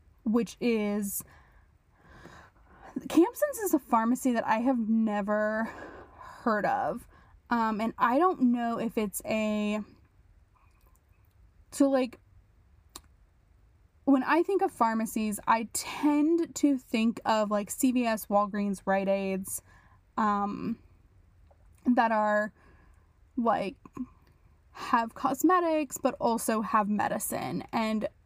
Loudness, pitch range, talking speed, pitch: -28 LUFS, 190-255 Hz, 100 wpm, 220 Hz